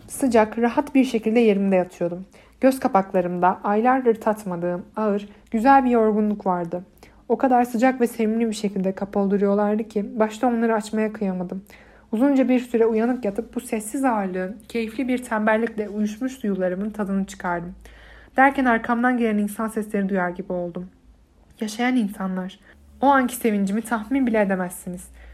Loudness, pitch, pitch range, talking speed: -22 LUFS, 220 Hz, 195-235 Hz, 140 wpm